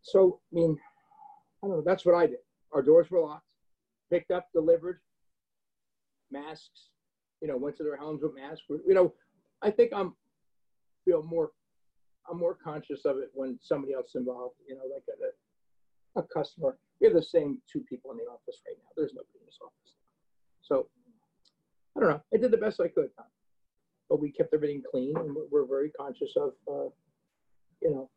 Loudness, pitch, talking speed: -30 LUFS, 210 Hz, 195 wpm